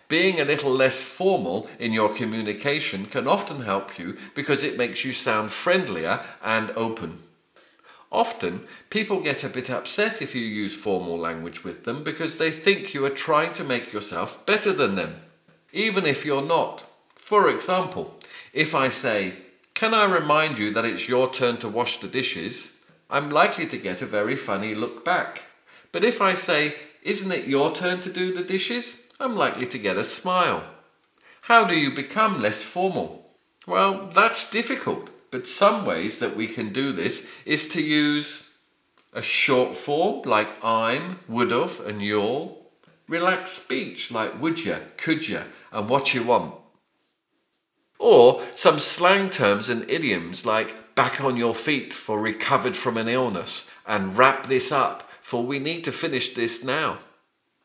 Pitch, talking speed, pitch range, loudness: 145 Hz, 165 wpm, 120-185 Hz, -22 LUFS